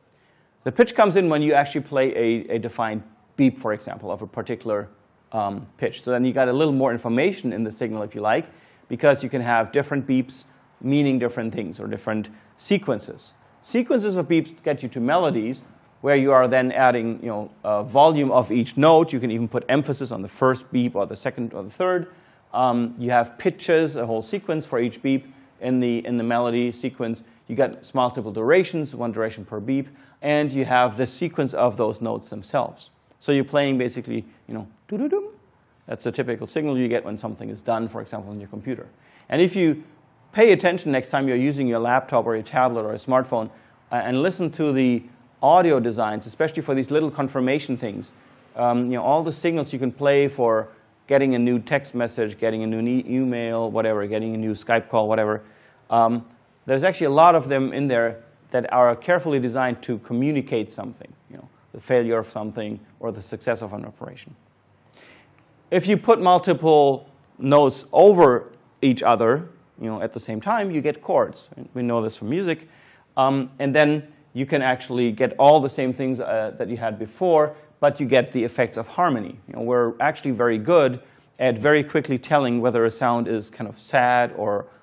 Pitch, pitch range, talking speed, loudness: 125 Hz, 115-145 Hz, 200 wpm, -22 LUFS